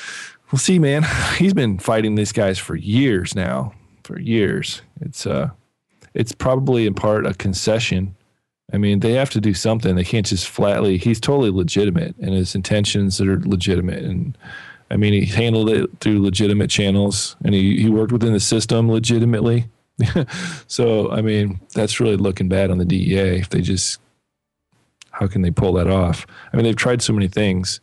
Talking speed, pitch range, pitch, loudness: 180 wpm, 95-115 Hz, 105 Hz, -18 LUFS